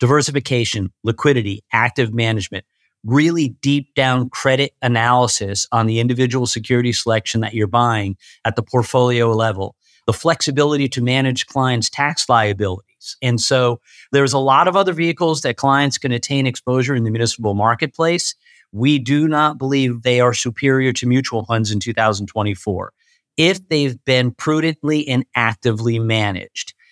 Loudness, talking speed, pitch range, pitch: -17 LUFS, 145 wpm, 115-140 Hz, 125 Hz